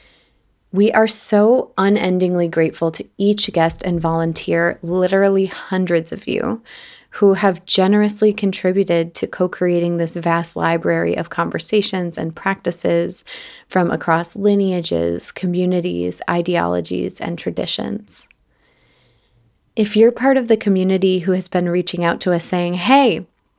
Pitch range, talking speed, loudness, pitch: 170-200 Hz, 125 wpm, -17 LUFS, 180 Hz